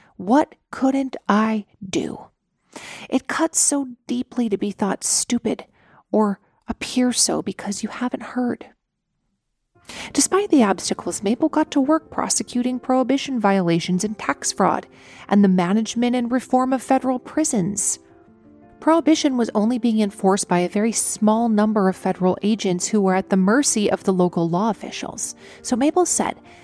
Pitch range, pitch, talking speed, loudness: 200-260 Hz, 225 Hz, 150 wpm, -20 LUFS